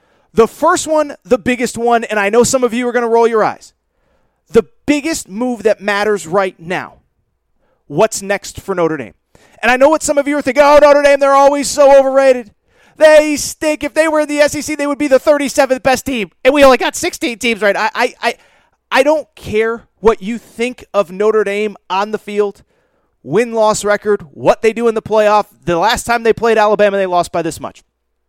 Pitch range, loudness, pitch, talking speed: 205-275 Hz, -13 LUFS, 230 Hz, 220 wpm